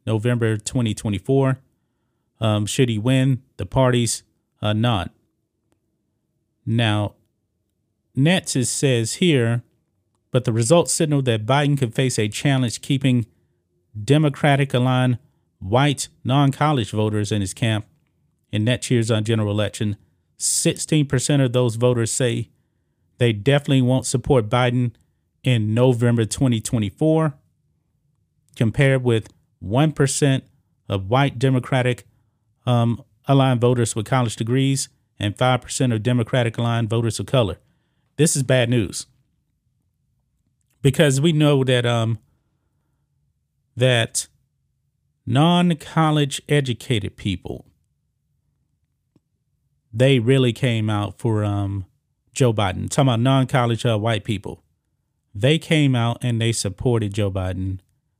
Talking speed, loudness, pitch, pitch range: 110 wpm, -20 LUFS, 120 Hz, 110-135 Hz